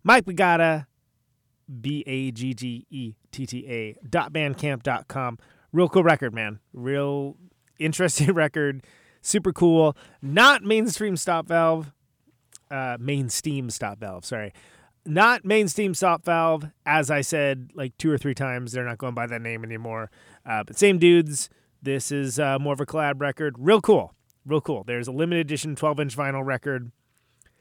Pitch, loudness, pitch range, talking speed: 140 Hz, -23 LUFS, 125-165 Hz, 165 wpm